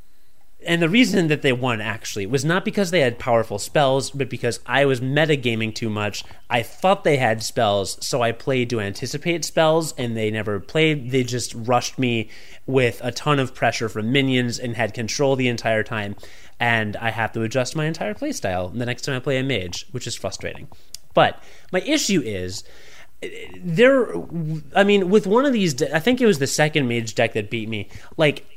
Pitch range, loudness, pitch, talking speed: 110-155 Hz, -21 LUFS, 125 Hz, 195 wpm